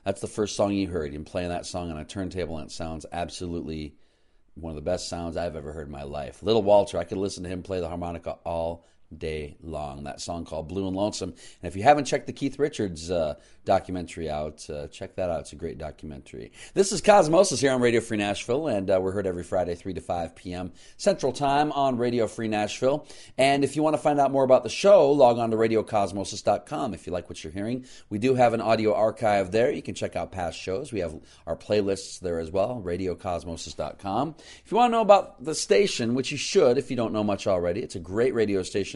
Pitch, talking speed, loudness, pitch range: 100 Hz, 240 wpm, -26 LUFS, 85-125 Hz